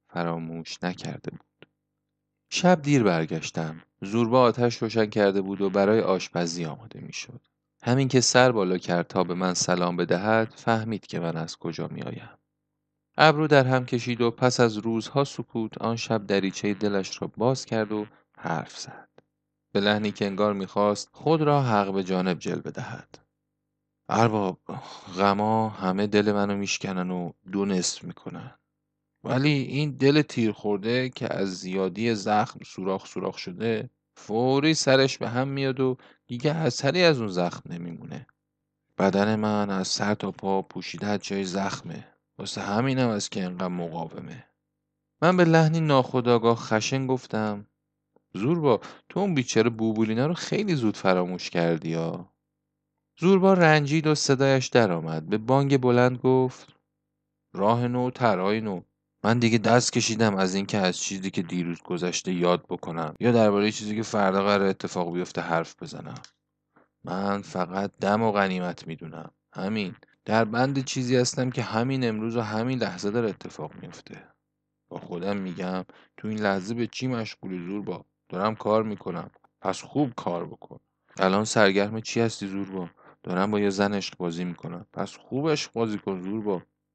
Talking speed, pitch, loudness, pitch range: 155 wpm, 110 Hz, -25 LUFS, 95-130 Hz